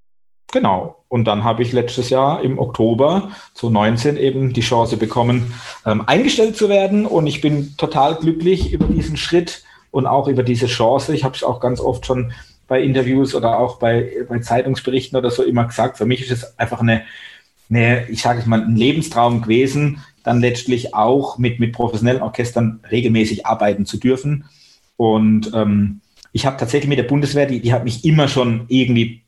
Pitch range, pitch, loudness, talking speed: 115-135 Hz, 125 Hz, -17 LUFS, 185 wpm